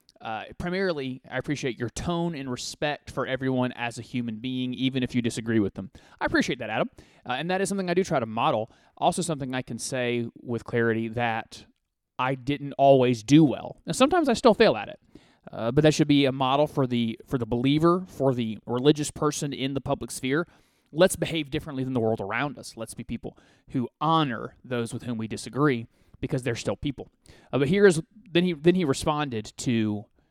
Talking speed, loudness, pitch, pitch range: 210 wpm, -26 LUFS, 130 Hz, 120-155 Hz